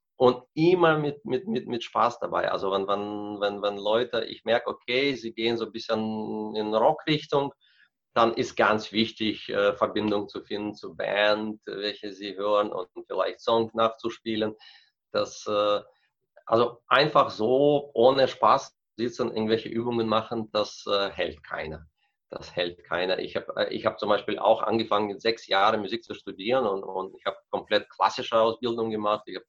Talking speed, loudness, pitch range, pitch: 160 wpm, -26 LUFS, 105-115 Hz, 110 Hz